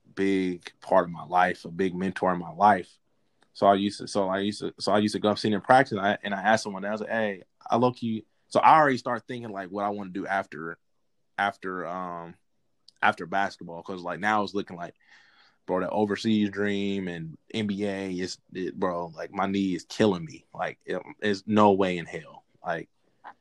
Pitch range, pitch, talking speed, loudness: 95-105 Hz, 100 Hz, 220 wpm, -27 LUFS